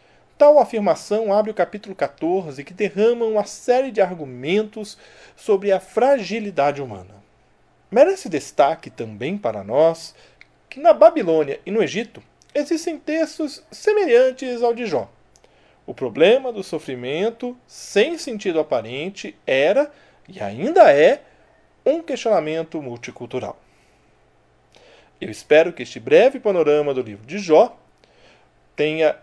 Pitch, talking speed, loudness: 205 Hz, 120 wpm, -19 LUFS